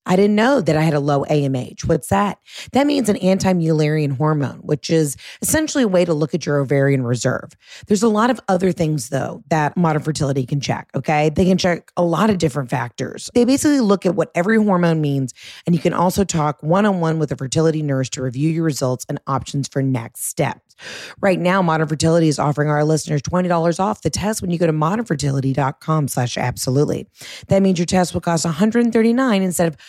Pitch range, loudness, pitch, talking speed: 145-185 Hz, -18 LUFS, 160 Hz, 205 wpm